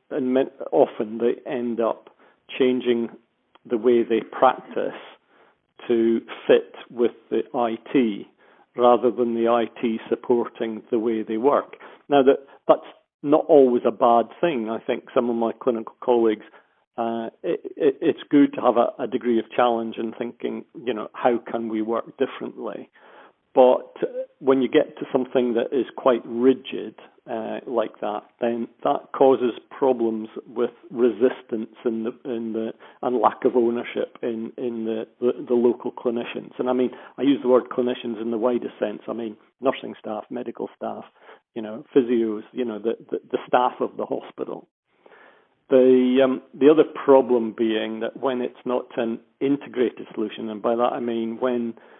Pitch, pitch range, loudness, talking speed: 120 Hz, 115-130 Hz, -23 LUFS, 165 wpm